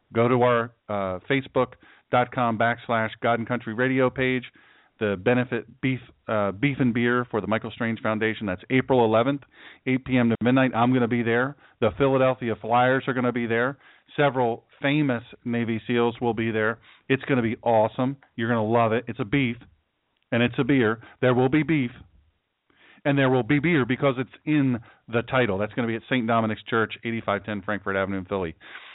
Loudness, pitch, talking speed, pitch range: -24 LUFS, 120 Hz, 205 wpm, 110-130 Hz